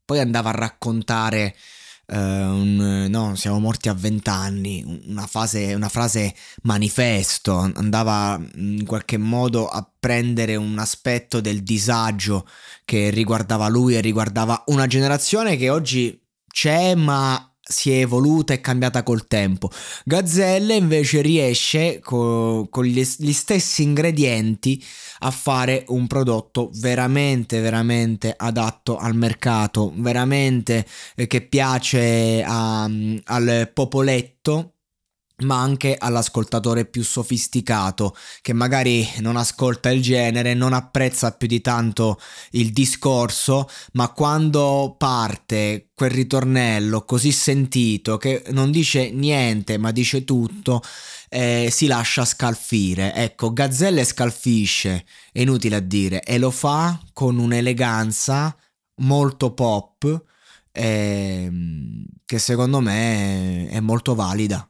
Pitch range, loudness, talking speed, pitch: 110-130 Hz, -20 LUFS, 115 wpm, 120 Hz